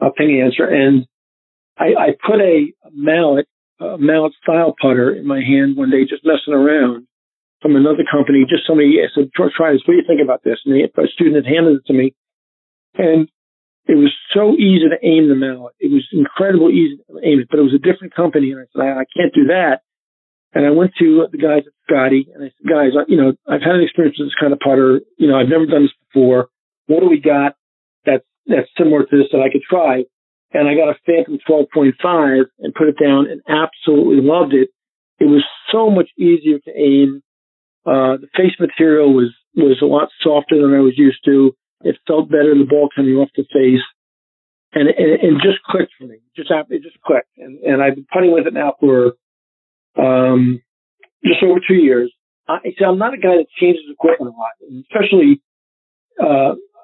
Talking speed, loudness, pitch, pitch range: 210 wpm, -14 LUFS, 145 Hz, 135-165 Hz